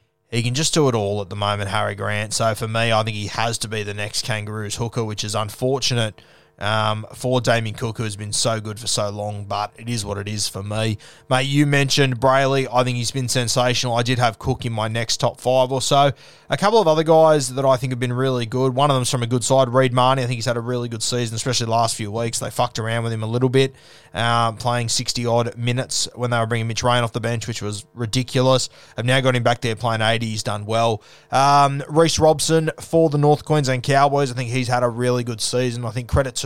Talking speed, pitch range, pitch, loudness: 260 wpm, 115-130 Hz, 120 Hz, -20 LUFS